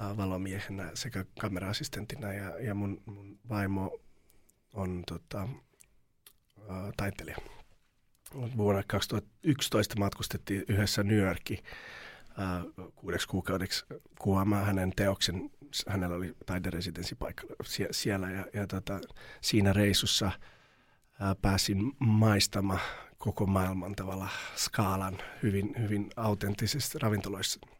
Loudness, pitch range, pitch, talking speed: -32 LUFS, 95-105 Hz, 100 Hz, 95 wpm